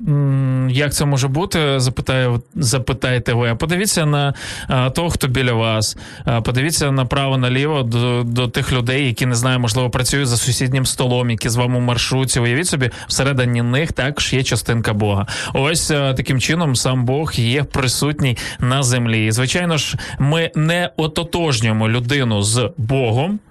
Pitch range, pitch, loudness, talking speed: 120-145 Hz, 130 Hz, -17 LUFS, 150 wpm